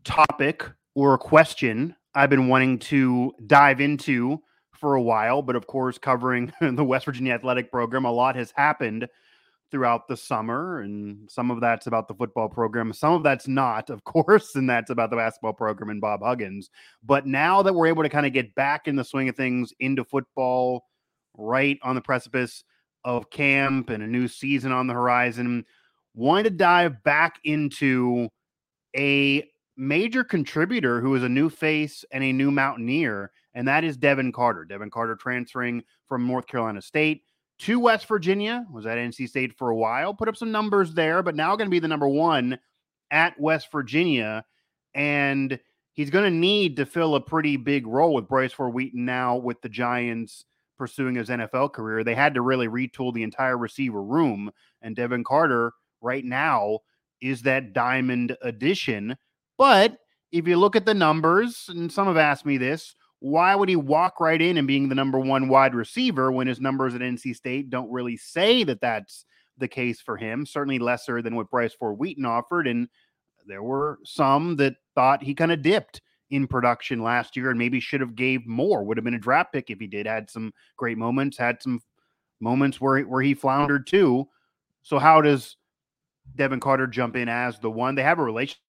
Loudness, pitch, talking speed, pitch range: -23 LUFS, 130 Hz, 190 wpm, 120-145 Hz